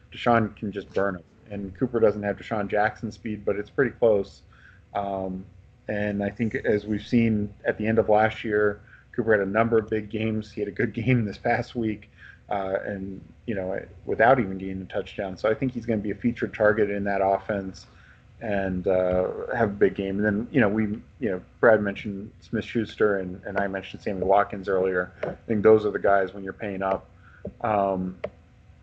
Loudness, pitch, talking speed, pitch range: -25 LUFS, 105 Hz, 210 wpm, 95-110 Hz